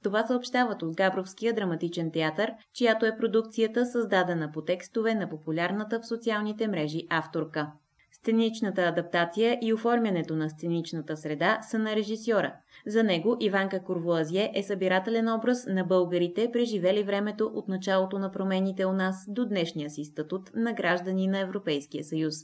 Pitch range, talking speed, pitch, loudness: 170-225 Hz, 145 wpm, 195 Hz, -28 LUFS